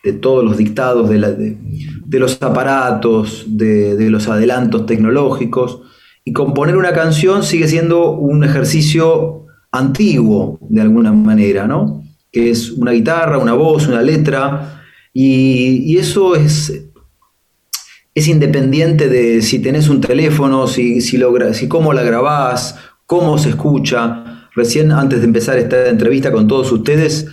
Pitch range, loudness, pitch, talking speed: 120-155 Hz, -12 LUFS, 135 Hz, 145 wpm